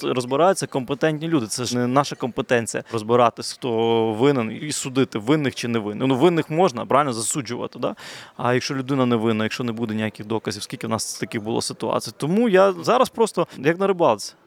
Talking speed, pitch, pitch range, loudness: 190 wpm, 130 Hz, 115-155 Hz, -22 LUFS